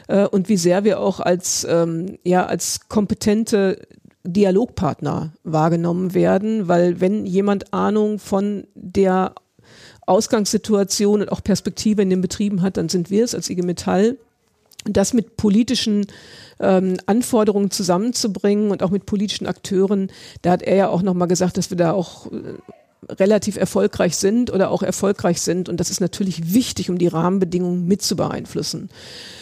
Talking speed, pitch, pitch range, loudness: 155 wpm, 195 Hz, 180-210 Hz, -19 LUFS